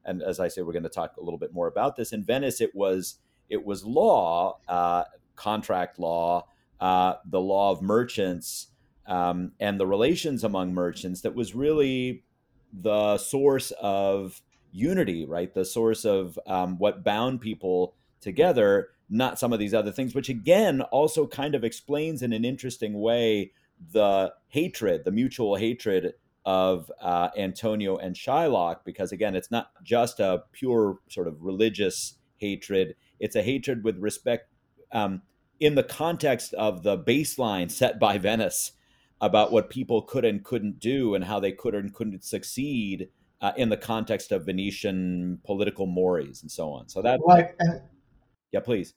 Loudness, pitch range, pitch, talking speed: -26 LUFS, 95-130 Hz, 105 Hz, 160 wpm